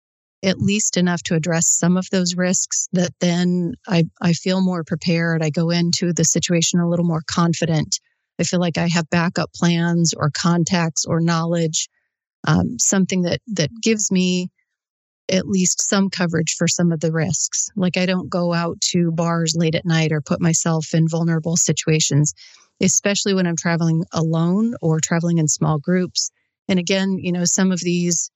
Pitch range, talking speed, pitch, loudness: 165-180 Hz, 180 wpm, 170 Hz, -19 LUFS